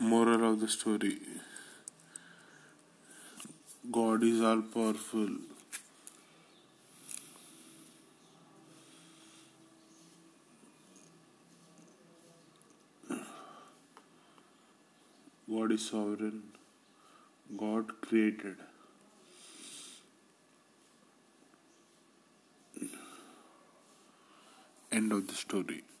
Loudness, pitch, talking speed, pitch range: -34 LUFS, 110 Hz, 40 wpm, 105-115 Hz